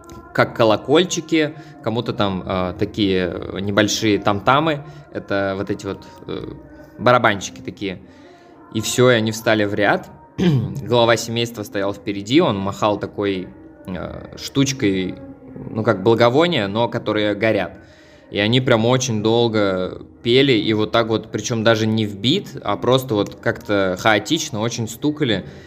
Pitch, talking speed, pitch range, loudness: 110 Hz, 135 wpm, 100-120 Hz, -19 LUFS